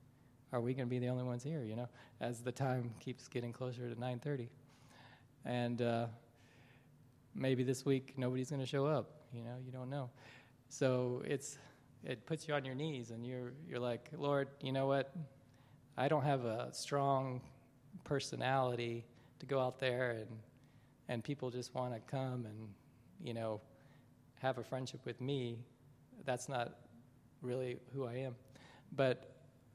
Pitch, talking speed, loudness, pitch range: 130 Hz, 165 wpm, -41 LUFS, 120-135 Hz